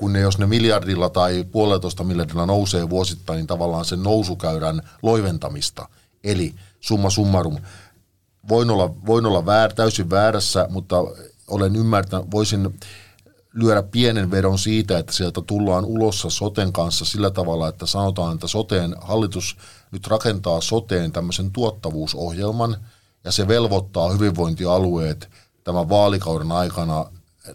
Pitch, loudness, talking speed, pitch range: 95 Hz, -20 LUFS, 125 wpm, 90-105 Hz